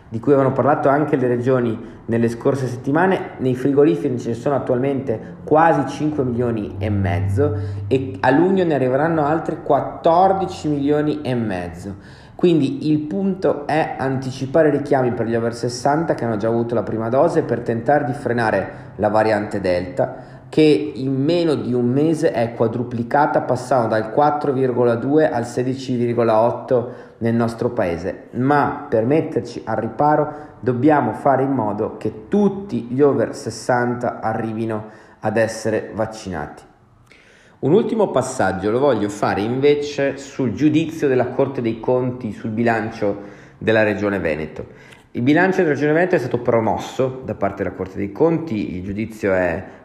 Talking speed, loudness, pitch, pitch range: 150 wpm, -19 LUFS, 125 Hz, 110-145 Hz